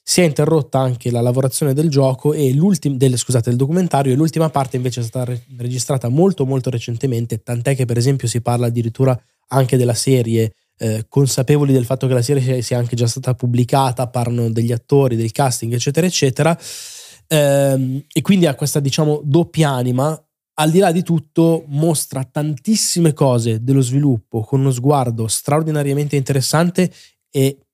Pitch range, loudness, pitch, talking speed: 125-150 Hz, -17 LUFS, 135 Hz, 165 wpm